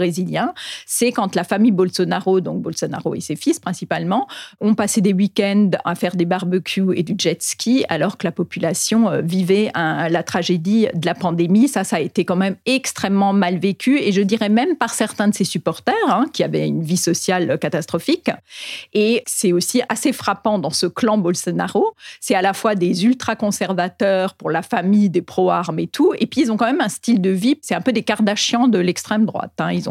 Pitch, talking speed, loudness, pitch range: 195 Hz, 205 wpm, -18 LUFS, 180-225 Hz